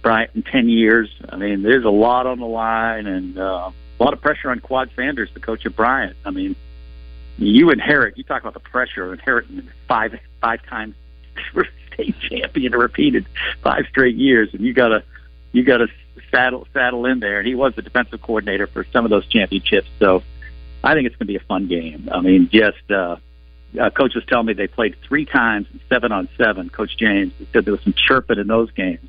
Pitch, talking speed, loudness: 105 Hz, 210 wpm, -18 LUFS